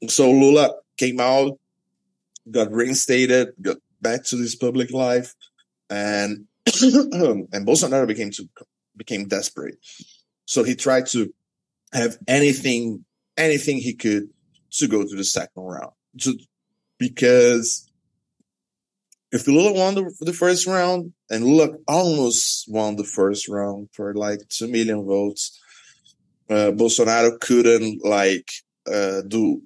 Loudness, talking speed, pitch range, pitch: -20 LUFS, 120 wpm, 105-135 Hz, 120 Hz